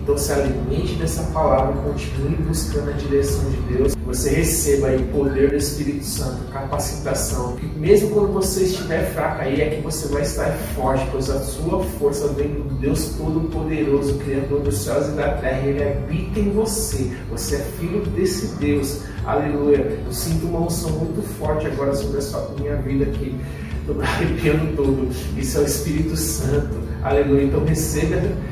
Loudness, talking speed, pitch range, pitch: -21 LUFS, 170 wpm, 120-150 Hz, 140 Hz